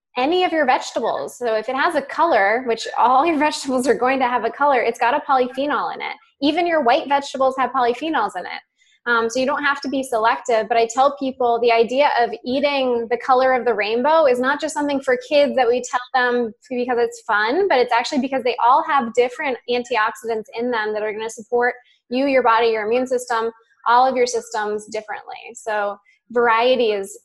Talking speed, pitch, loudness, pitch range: 215 wpm, 250 Hz, -19 LUFS, 230-280 Hz